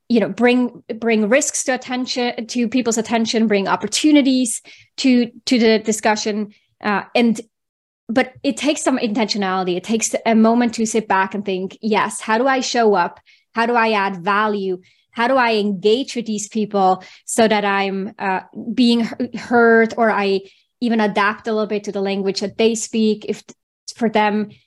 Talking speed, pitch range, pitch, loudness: 175 wpm, 205-240 Hz, 225 Hz, -18 LUFS